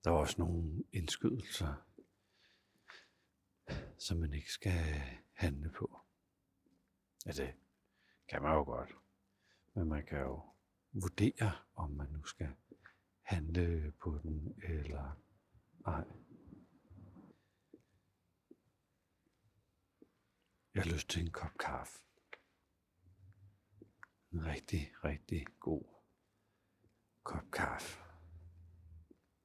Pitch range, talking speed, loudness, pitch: 75-95 Hz, 90 wpm, -41 LUFS, 85 Hz